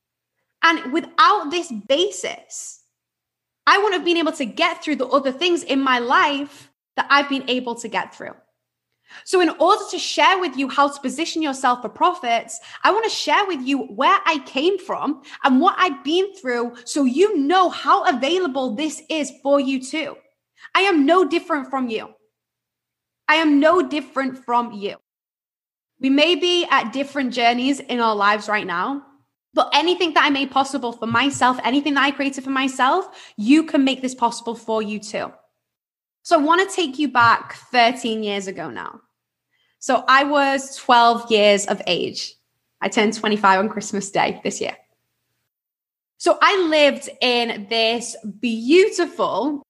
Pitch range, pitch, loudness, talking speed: 235-325 Hz, 275 Hz, -19 LUFS, 170 wpm